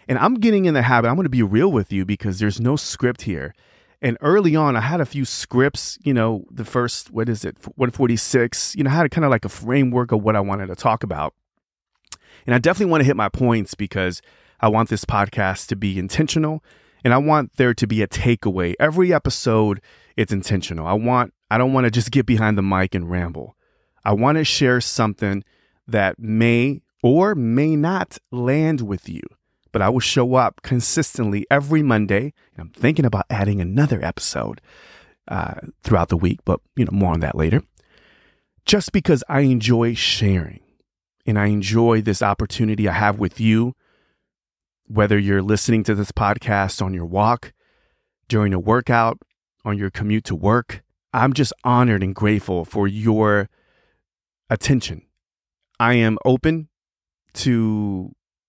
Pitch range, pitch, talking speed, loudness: 100-130 Hz, 110 Hz, 175 wpm, -19 LUFS